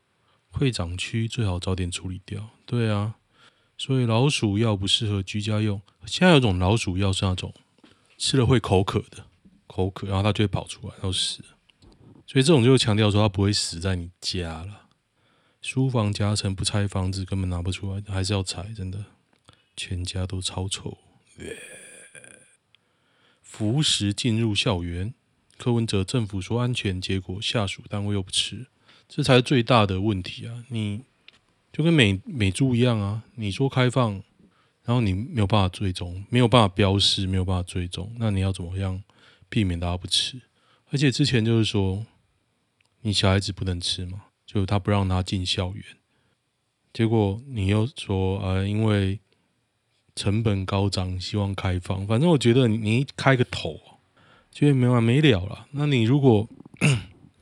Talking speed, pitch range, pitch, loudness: 245 characters per minute, 95-120 Hz, 105 Hz, -24 LUFS